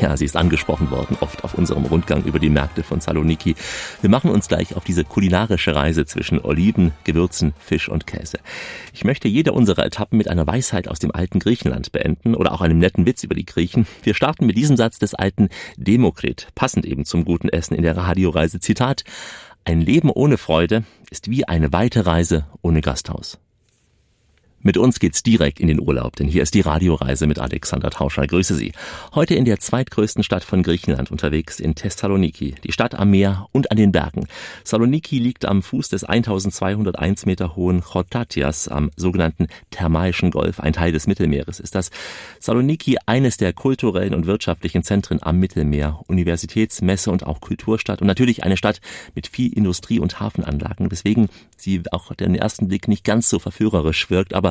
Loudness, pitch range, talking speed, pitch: -19 LUFS, 80-105 Hz, 185 wpm, 90 Hz